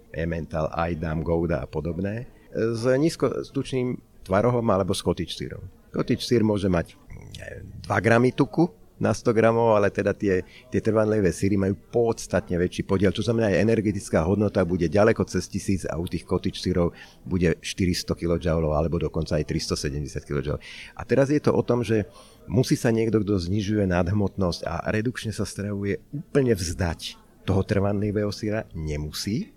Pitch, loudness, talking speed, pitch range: 100 Hz, -25 LUFS, 155 wpm, 90-115 Hz